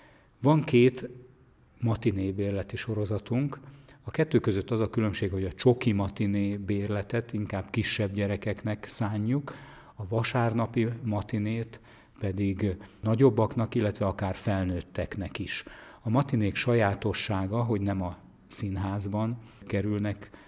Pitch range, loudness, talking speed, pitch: 100-120 Hz, -29 LUFS, 110 wpm, 110 Hz